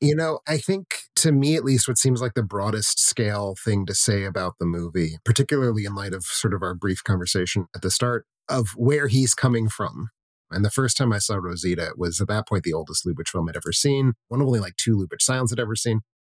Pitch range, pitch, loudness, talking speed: 95-130 Hz, 110 Hz, -23 LUFS, 245 wpm